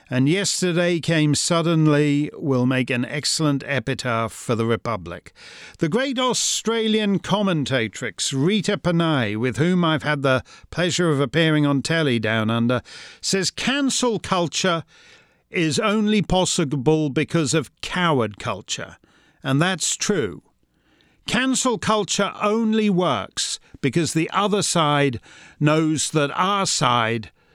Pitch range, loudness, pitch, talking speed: 135-185 Hz, -21 LUFS, 155 Hz, 120 wpm